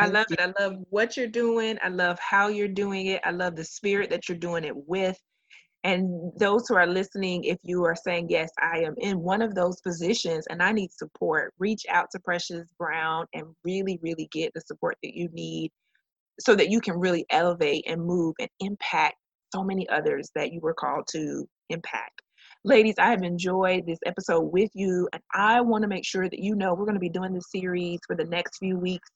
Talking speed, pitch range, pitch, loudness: 220 wpm, 175-200 Hz, 185 Hz, -26 LUFS